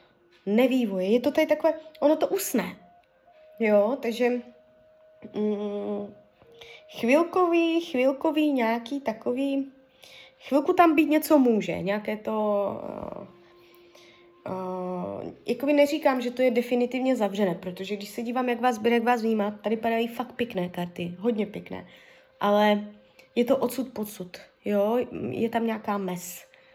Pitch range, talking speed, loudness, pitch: 205-265 Hz, 130 wpm, -26 LUFS, 235 Hz